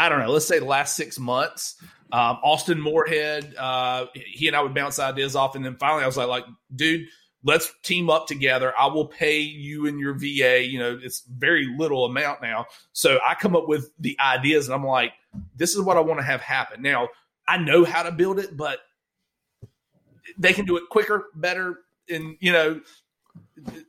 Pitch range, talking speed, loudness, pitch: 135-170 Hz, 205 wpm, -22 LUFS, 150 Hz